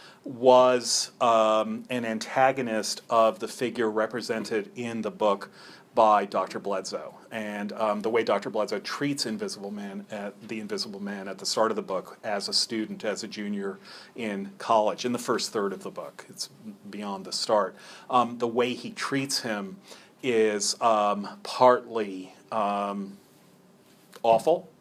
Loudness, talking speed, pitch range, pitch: -27 LUFS, 150 wpm, 105-125 Hz, 110 Hz